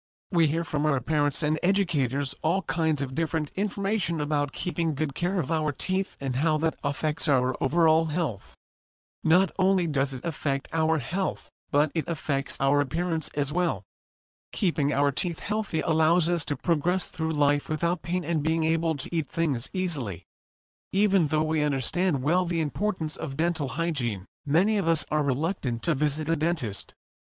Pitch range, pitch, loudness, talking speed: 140-170 Hz, 155 Hz, -27 LUFS, 170 wpm